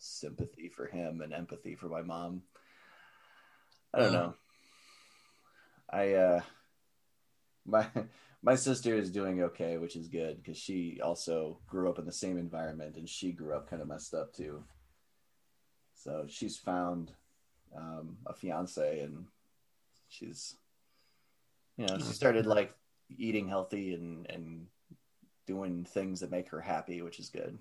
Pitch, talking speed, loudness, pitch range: 90 Hz, 145 wpm, -36 LUFS, 85-95 Hz